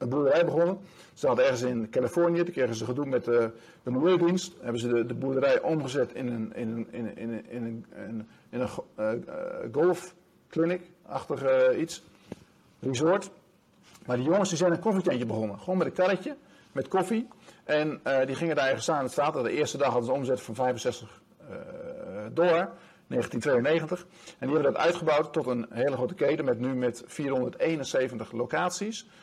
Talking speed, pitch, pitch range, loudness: 160 wpm, 150 Hz, 120-180 Hz, -28 LUFS